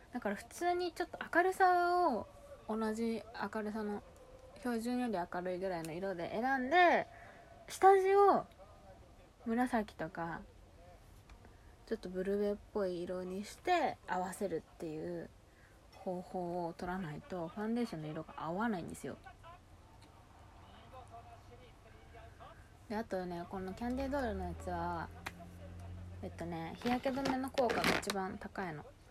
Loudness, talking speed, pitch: -36 LUFS, 265 characters per minute, 185 Hz